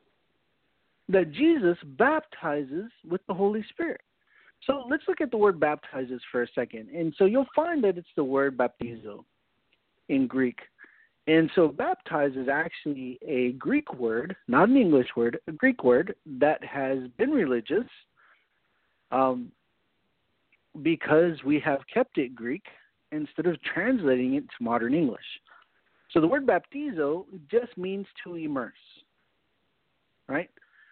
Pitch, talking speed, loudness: 165 Hz, 135 wpm, -27 LUFS